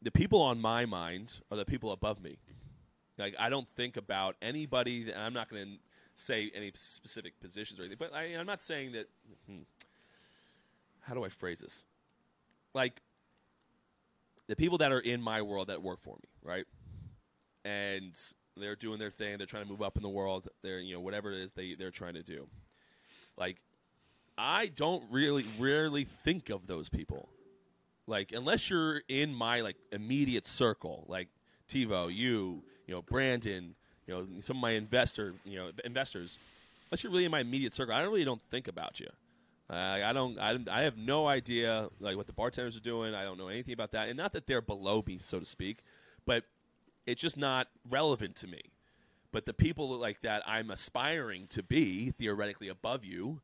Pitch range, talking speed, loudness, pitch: 100-125 Hz, 190 wpm, -35 LUFS, 110 Hz